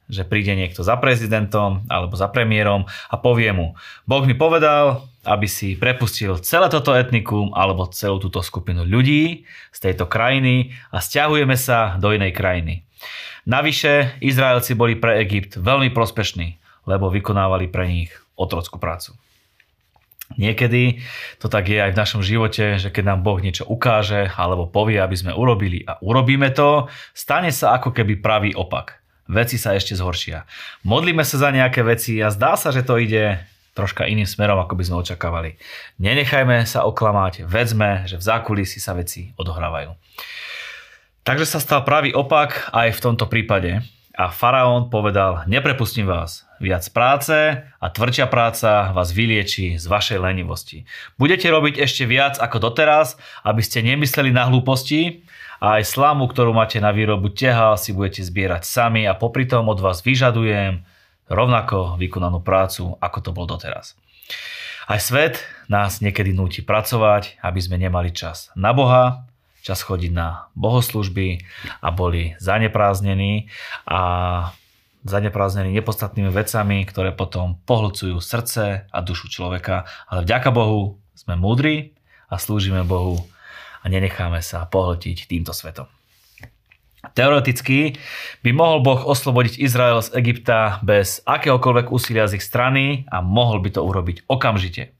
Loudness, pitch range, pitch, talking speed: -18 LUFS, 95-125 Hz, 105 Hz, 145 wpm